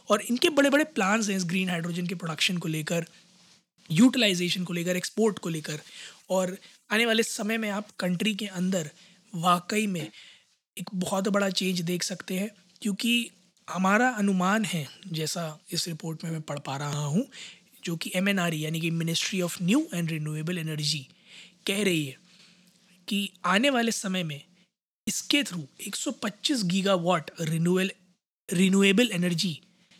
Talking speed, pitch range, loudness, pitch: 150 wpm, 170-205 Hz, -27 LUFS, 185 Hz